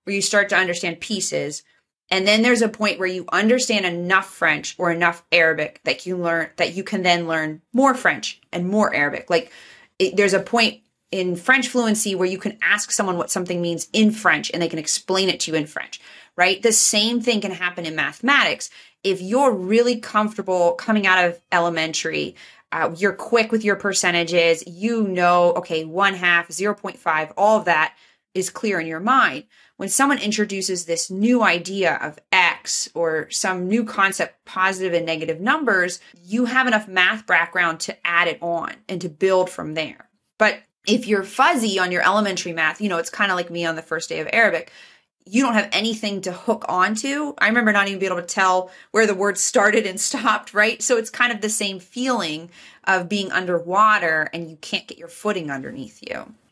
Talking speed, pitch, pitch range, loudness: 200 wpm, 190 Hz, 175-215 Hz, -20 LUFS